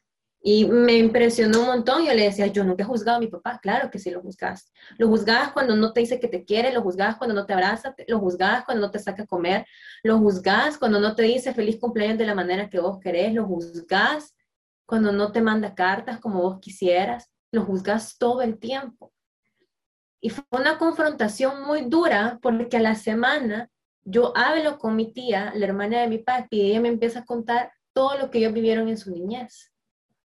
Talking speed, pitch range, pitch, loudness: 210 wpm, 205-245 Hz, 225 Hz, -23 LUFS